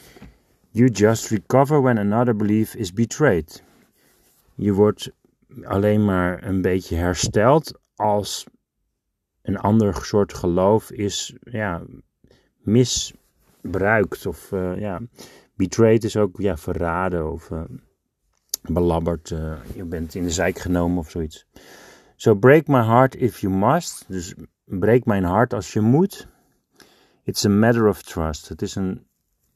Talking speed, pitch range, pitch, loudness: 130 wpm, 90-115 Hz, 100 Hz, -20 LUFS